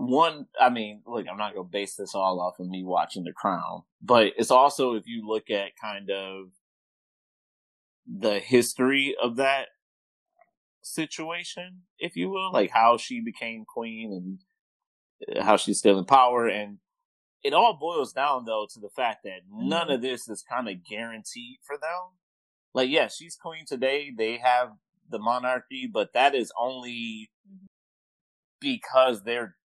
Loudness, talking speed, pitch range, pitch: -26 LUFS, 160 wpm, 110-180 Hz, 125 Hz